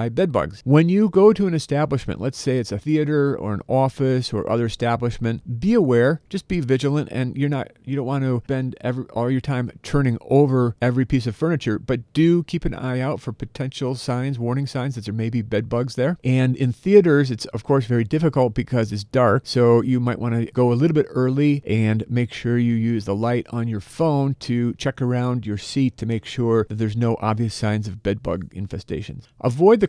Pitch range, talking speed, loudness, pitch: 115-140 Hz, 215 wpm, -21 LUFS, 125 Hz